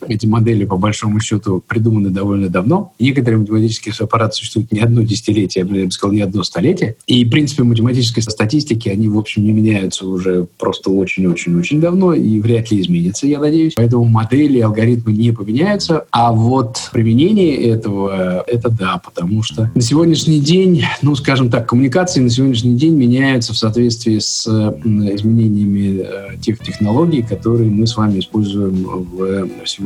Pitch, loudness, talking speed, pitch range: 110 Hz, -14 LUFS, 160 wpm, 105-125 Hz